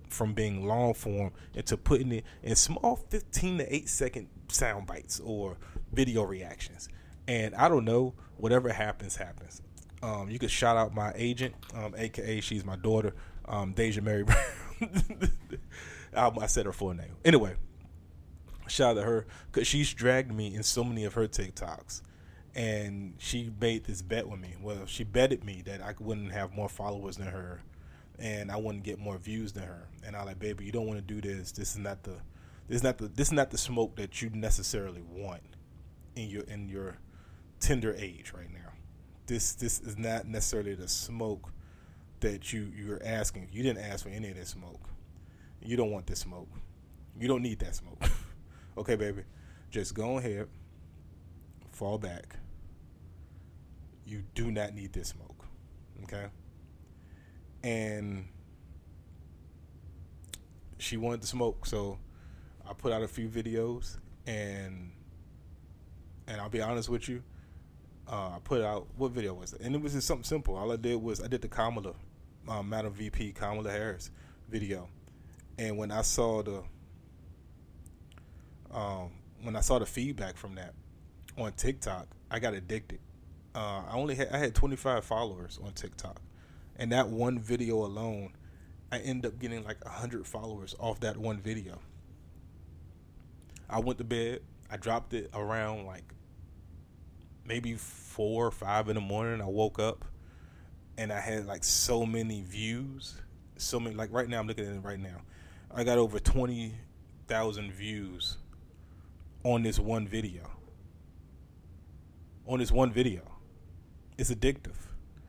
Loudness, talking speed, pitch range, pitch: -33 LUFS, 160 wpm, 85-110 Hz, 100 Hz